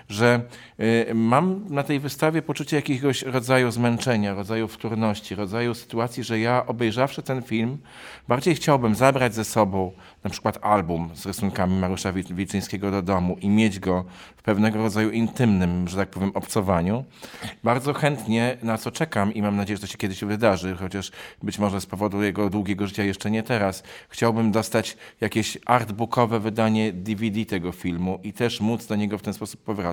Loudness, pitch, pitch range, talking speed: -24 LUFS, 110 Hz, 100-120 Hz, 170 wpm